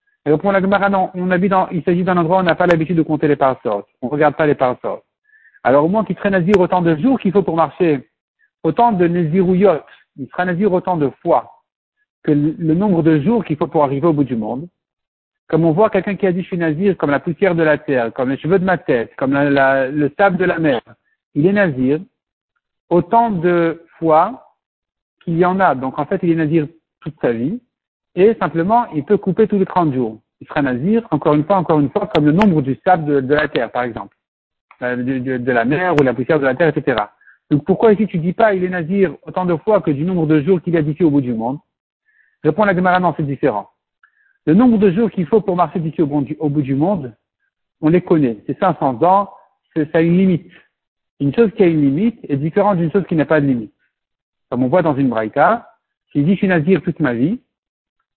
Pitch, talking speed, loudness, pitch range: 170 Hz, 245 wpm, -16 LUFS, 150-195 Hz